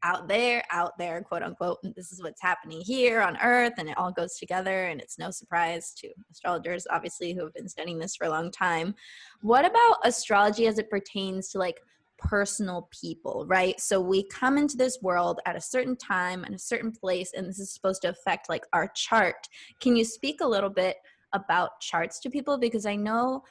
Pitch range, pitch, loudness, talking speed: 175-235 Hz, 195 Hz, -27 LUFS, 210 wpm